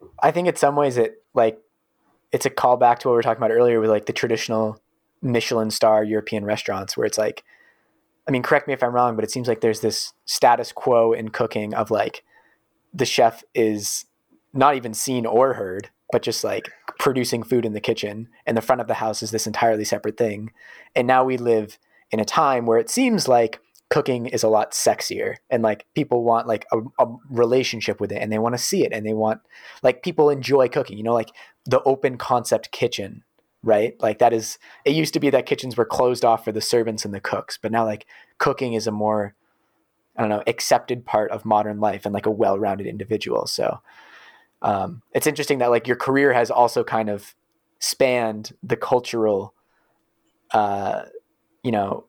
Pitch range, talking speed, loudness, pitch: 110-130 Hz, 205 wpm, -21 LUFS, 115 Hz